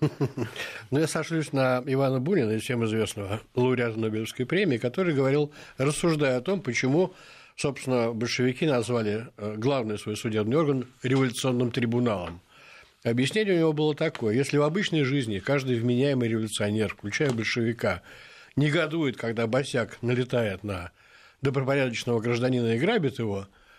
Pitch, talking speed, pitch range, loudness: 125 Hz, 130 wpm, 115-140 Hz, -27 LUFS